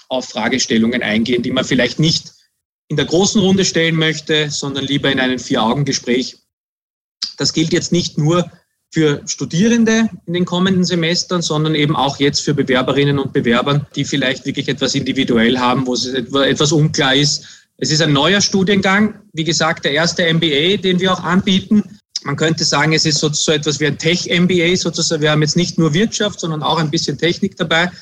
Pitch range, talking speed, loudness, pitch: 140-175 Hz, 180 wpm, -15 LUFS, 155 Hz